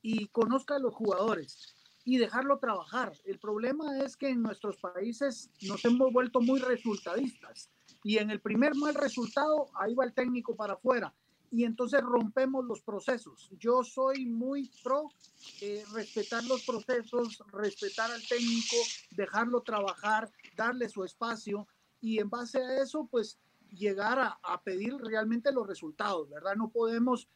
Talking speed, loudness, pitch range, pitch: 150 wpm, -32 LUFS, 210-255 Hz, 235 Hz